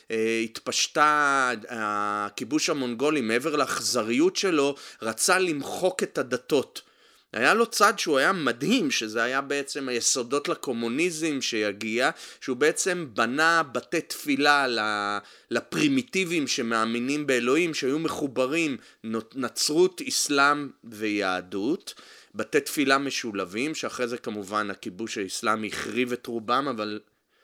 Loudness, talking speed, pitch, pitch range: -25 LUFS, 105 wpm, 135 Hz, 110-165 Hz